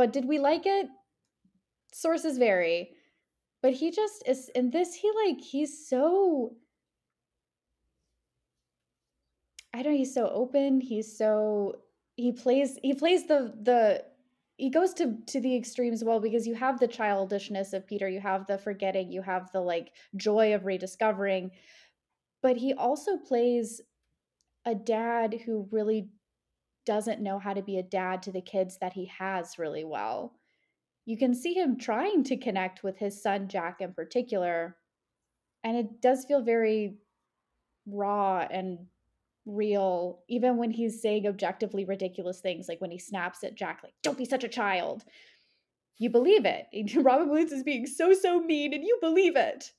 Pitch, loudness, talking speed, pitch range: 225 Hz, -29 LUFS, 160 wpm, 195-265 Hz